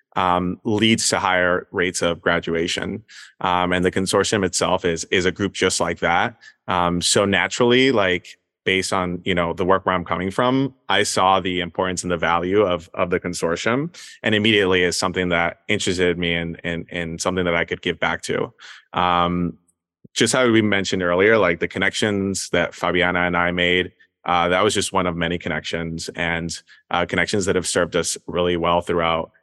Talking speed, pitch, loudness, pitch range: 190 wpm, 90 Hz, -20 LUFS, 85-95 Hz